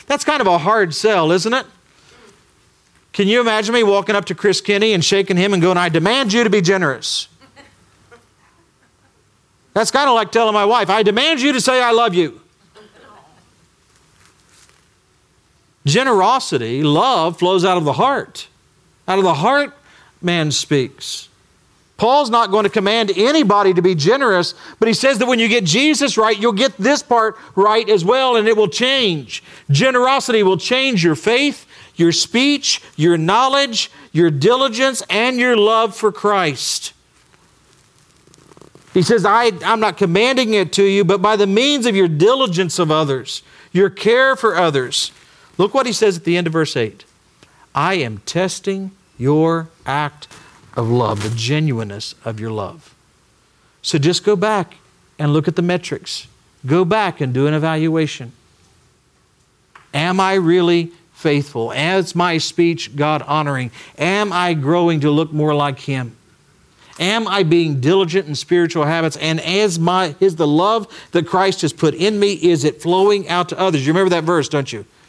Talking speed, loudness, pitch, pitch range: 165 wpm, -16 LUFS, 180 Hz, 155-215 Hz